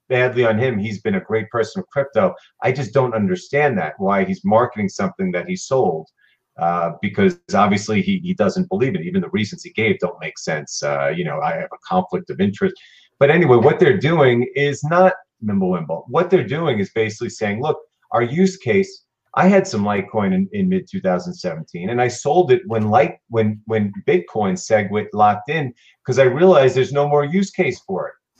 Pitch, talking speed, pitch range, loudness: 160 Hz, 200 wpm, 120-185 Hz, -18 LUFS